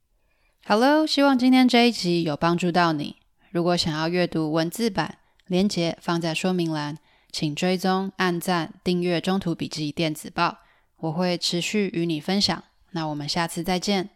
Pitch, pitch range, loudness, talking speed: 175 Hz, 165-190 Hz, -23 LUFS, 250 characters per minute